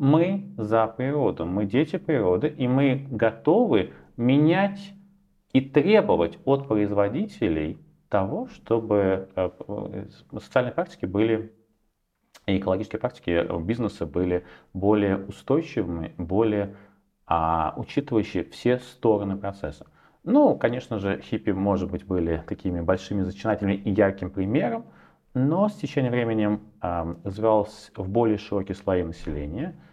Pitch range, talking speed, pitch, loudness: 95-125 Hz, 110 wpm, 105 Hz, -25 LUFS